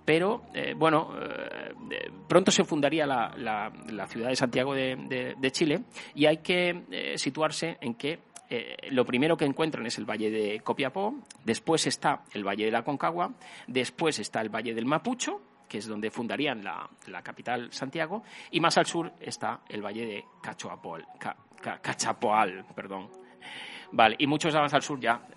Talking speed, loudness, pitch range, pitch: 175 wpm, -29 LUFS, 115-170 Hz, 145 Hz